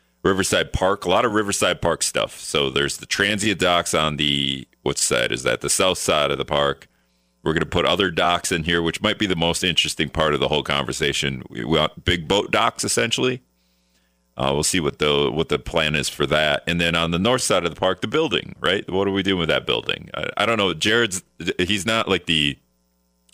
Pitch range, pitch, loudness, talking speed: 70-95 Hz, 85 Hz, -20 LUFS, 230 wpm